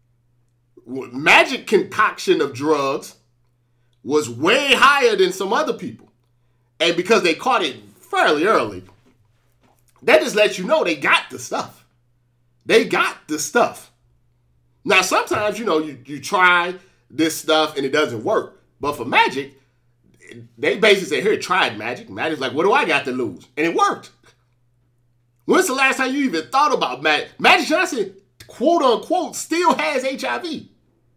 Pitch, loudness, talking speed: 135 Hz, -18 LUFS, 155 wpm